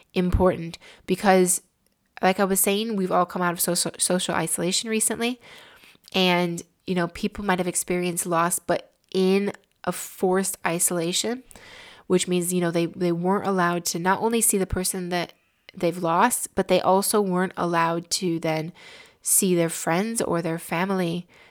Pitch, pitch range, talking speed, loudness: 185 Hz, 175-195 Hz, 160 wpm, -23 LUFS